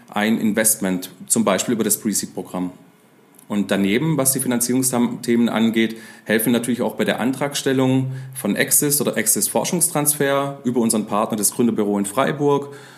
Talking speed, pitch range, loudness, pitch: 150 wpm, 110-135 Hz, -19 LUFS, 120 Hz